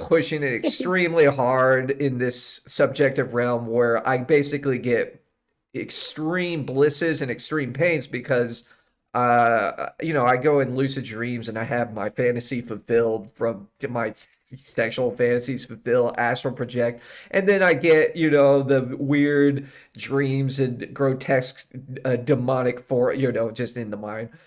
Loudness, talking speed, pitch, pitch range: -22 LUFS, 145 wpm, 130 Hz, 120-140 Hz